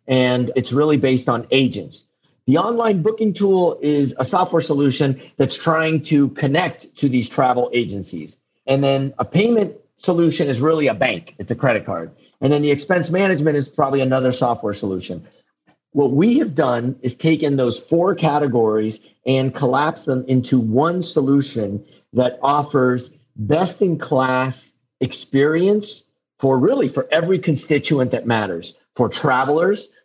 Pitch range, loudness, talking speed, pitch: 130-160 Hz, -18 LUFS, 145 wpm, 140 Hz